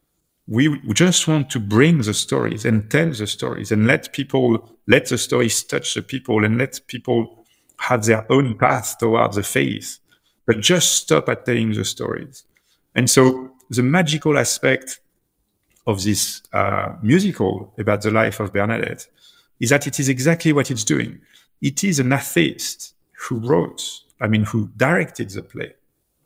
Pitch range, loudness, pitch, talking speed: 110-140 Hz, -19 LUFS, 125 Hz, 160 wpm